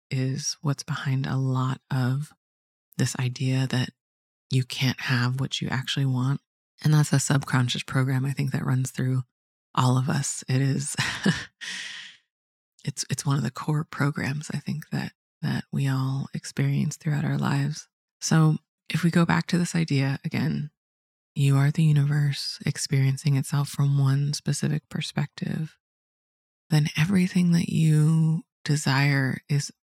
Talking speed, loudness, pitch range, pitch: 145 wpm, -25 LUFS, 130-155 Hz, 140 Hz